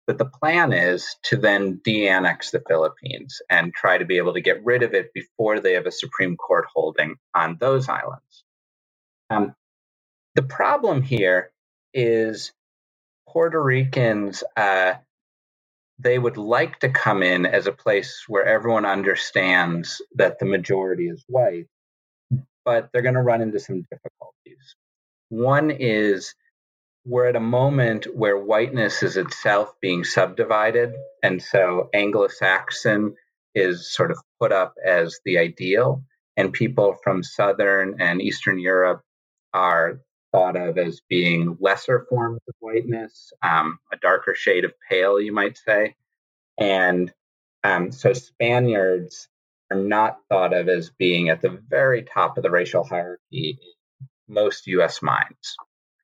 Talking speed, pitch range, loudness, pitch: 140 wpm, 90-130 Hz, -21 LUFS, 110 Hz